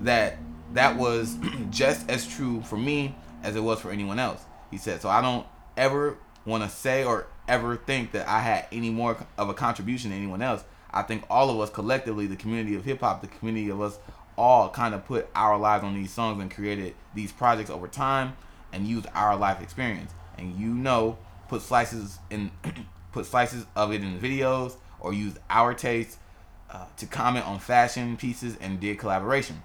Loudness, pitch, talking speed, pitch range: -27 LUFS, 110 Hz, 195 wpm, 100-120 Hz